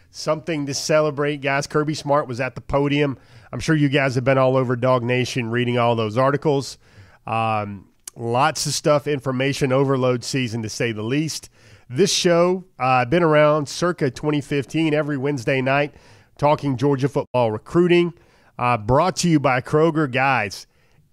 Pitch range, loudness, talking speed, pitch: 120-150 Hz, -20 LUFS, 160 wpm, 140 Hz